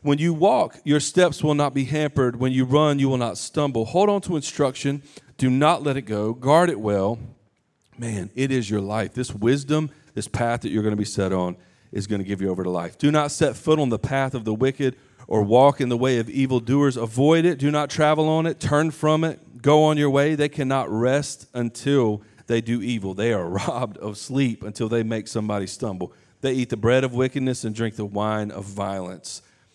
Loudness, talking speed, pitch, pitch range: -22 LUFS, 225 wpm, 130 Hz, 110-145 Hz